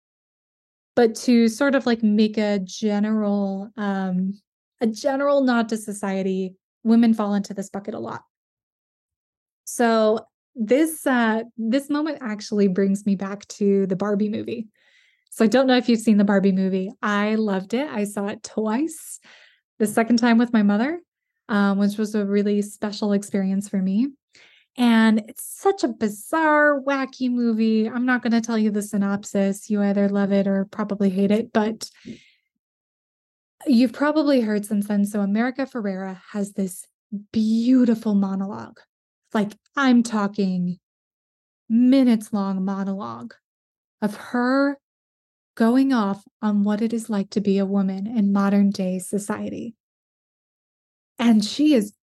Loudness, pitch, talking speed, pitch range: -22 LUFS, 215 Hz, 145 wpm, 200-240 Hz